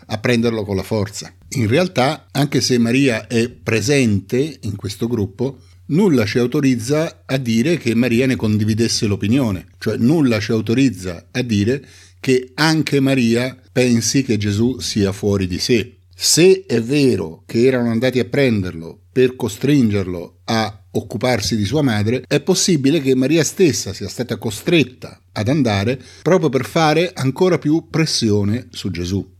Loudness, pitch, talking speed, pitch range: -17 LUFS, 120 Hz, 150 wpm, 105-135 Hz